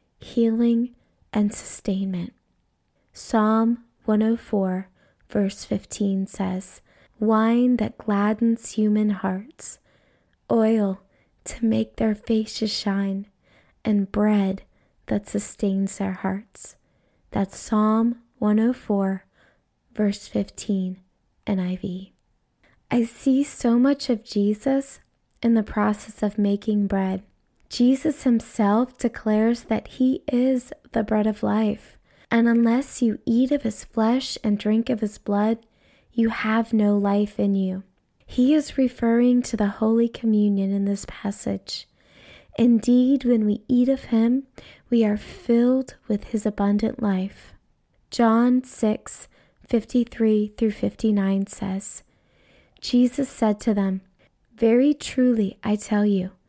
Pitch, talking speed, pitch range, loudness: 220 Hz, 115 wpm, 200-235 Hz, -23 LUFS